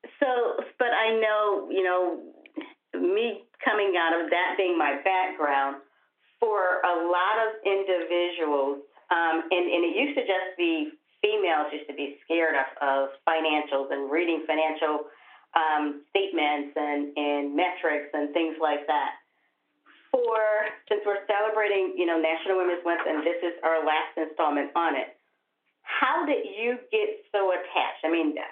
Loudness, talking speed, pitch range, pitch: -26 LUFS, 150 wpm, 155-210 Hz, 175 Hz